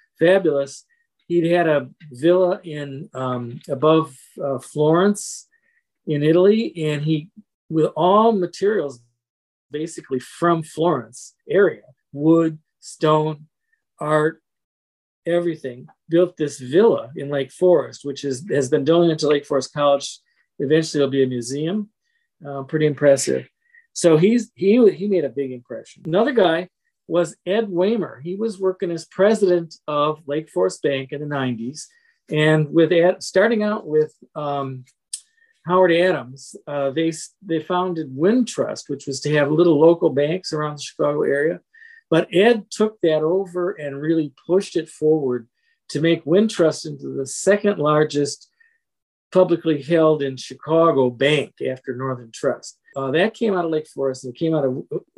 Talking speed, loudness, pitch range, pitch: 150 wpm, -20 LUFS, 140-185 Hz, 160 Hz